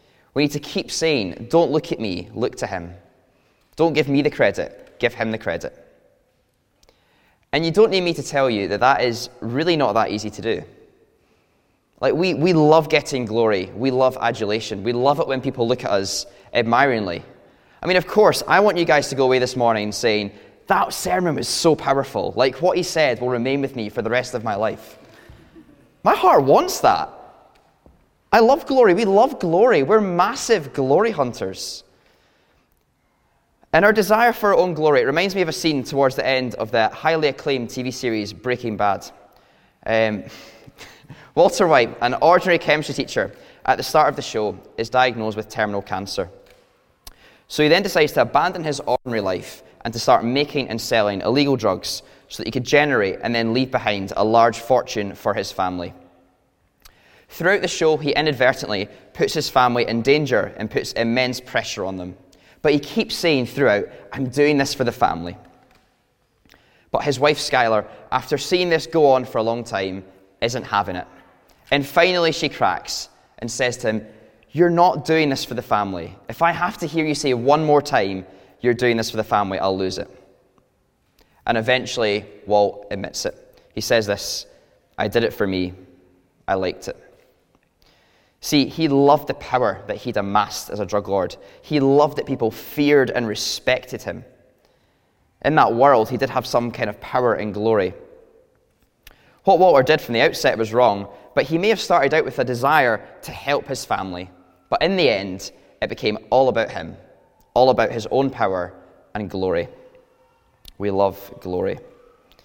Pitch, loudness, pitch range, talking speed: 125 Hz, -20 LUFS, 105-155 Hz, 180 wpm